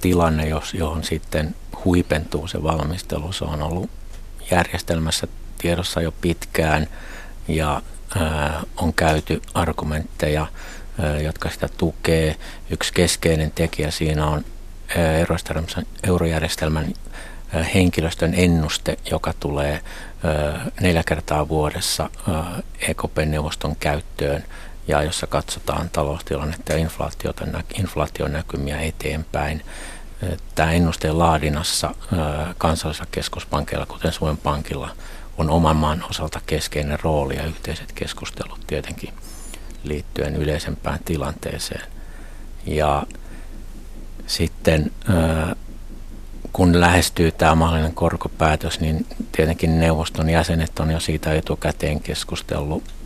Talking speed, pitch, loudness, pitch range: 90 wpm, 80 Hz, -22 LUFS, 75-85 Hz